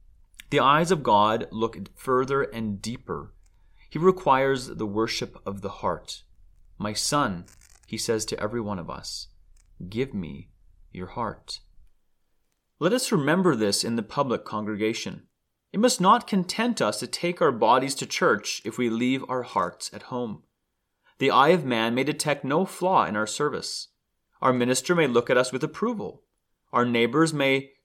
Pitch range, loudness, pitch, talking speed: 110-155 Hz, -25 LUFS, 125 Hz, 165 wpm